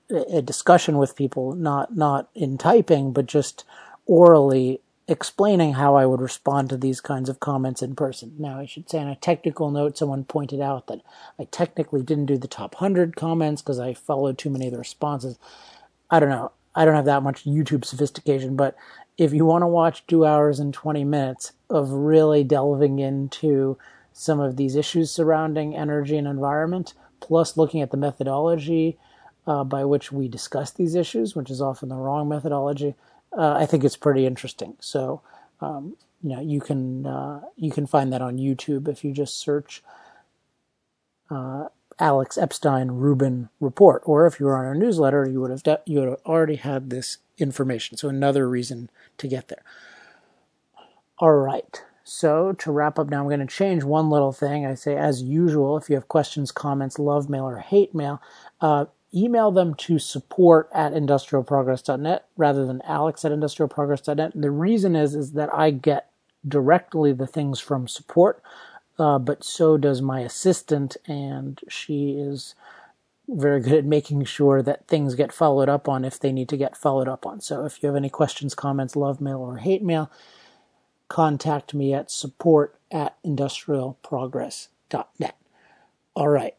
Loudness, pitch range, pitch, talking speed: -22 LUFS, 135-155 Hz, 145 Hz, 175 wpm